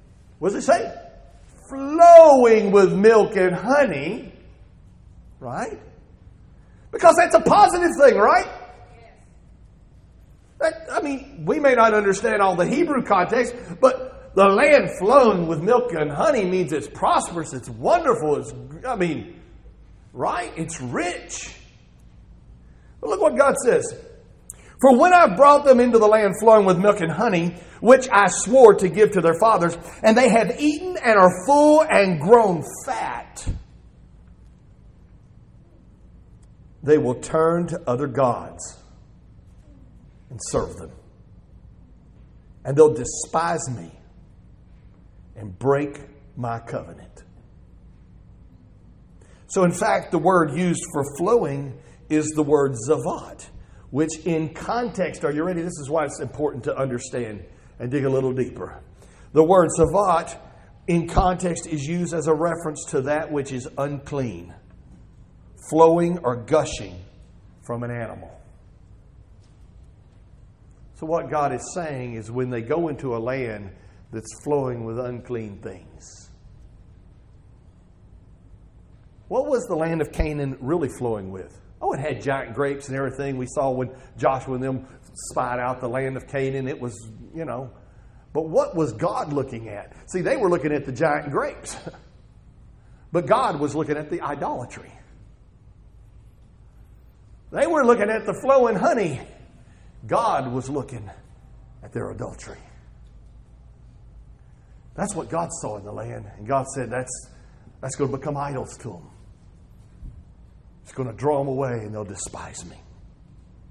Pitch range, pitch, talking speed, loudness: 115-185 Hz, 145 Hz, 140 wpm, -20 LUFS